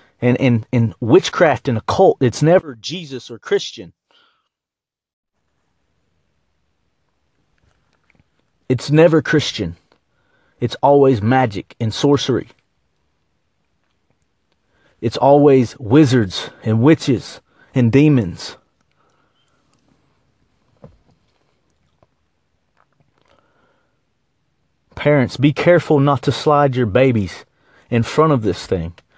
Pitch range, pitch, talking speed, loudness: 105-145 Hz, 130 Hz, 80 wpm, -16 LUFS